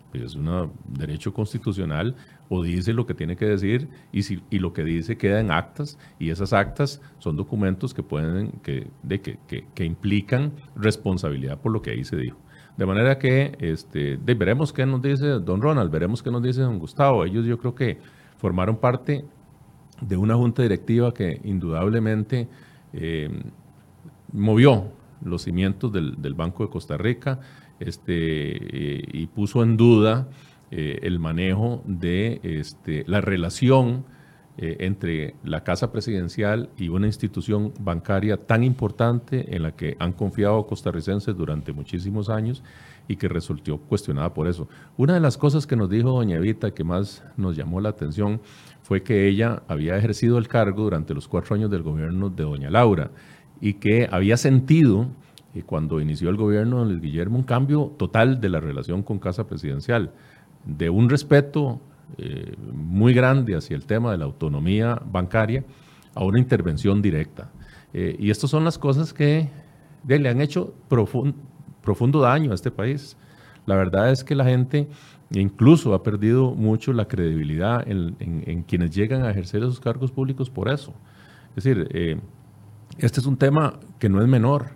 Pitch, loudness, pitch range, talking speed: 110 Hz, -23 LUFS, 95-130 Hz, 170 wpm